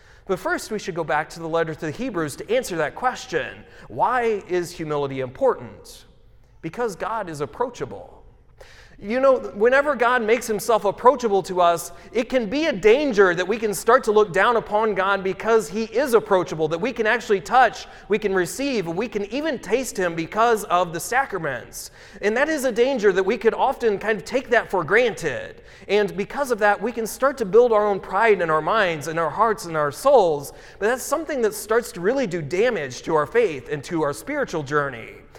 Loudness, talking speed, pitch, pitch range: -21 LUFS, 205 wpm, 215 Hz, 180-250 Hz